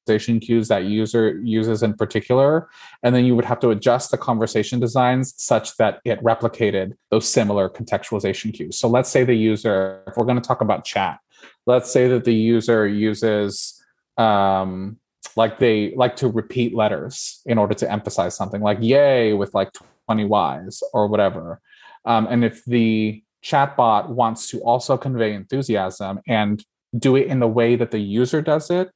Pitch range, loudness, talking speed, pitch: 105-120 Hz, -20 LUFS, 175 wpm, 115 Hz